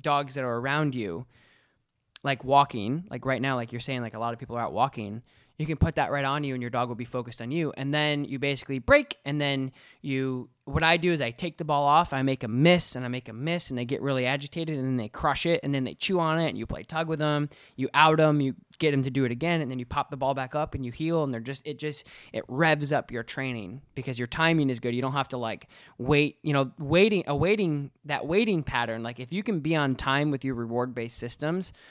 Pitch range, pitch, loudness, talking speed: 125-155 Hz, 140 Hz, -27 LUFS, 275 wpm